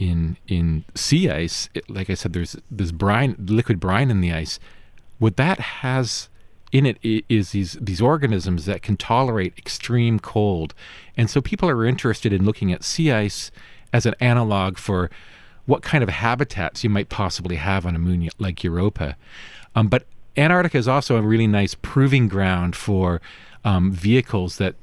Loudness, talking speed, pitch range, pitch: -21 LUFS, 170 wpm, 90-120 Hz, 100 Hz